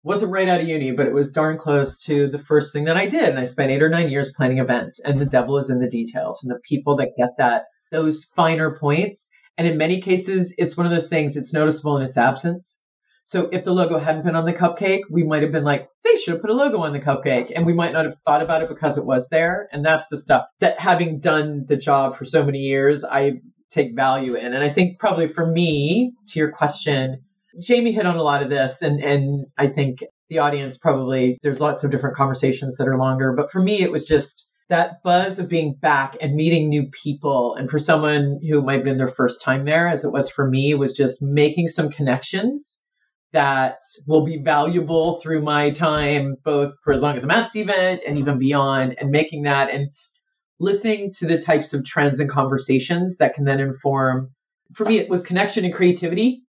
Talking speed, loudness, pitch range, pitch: 230 wpm, -20 LUFS, 140-170 Hz, 150 Hz